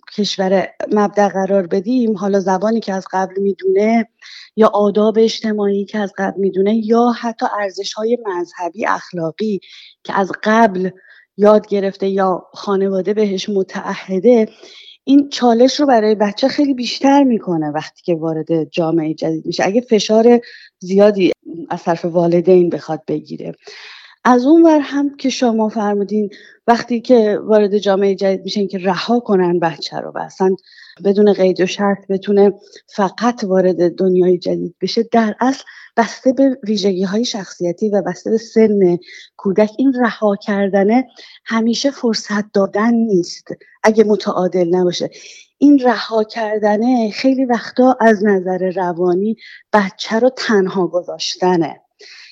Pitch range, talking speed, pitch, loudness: 190-230 Hz, 135 wpm, 205 Hz, -15 LUFS